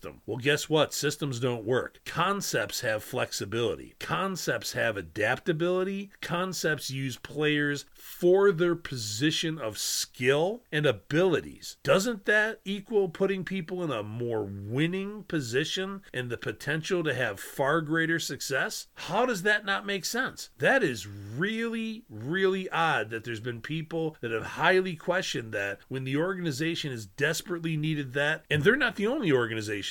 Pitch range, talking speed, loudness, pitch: 130-190 Hz, 145 wpm, -29 LUFS, 155 Hz